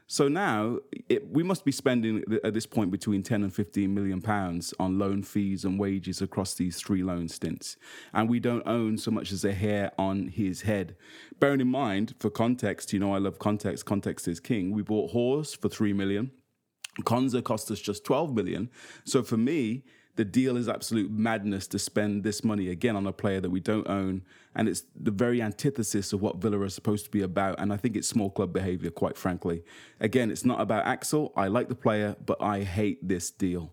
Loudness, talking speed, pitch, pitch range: -29 LUFS, 210 wpm, 105 Hz, 95-115 Hz